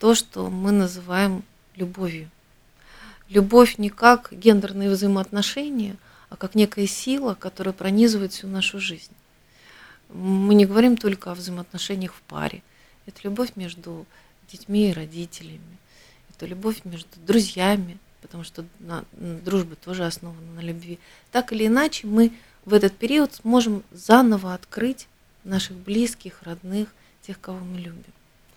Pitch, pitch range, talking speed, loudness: 195 Hz, 180-215 Hz, 130 wpm, -22 LUFS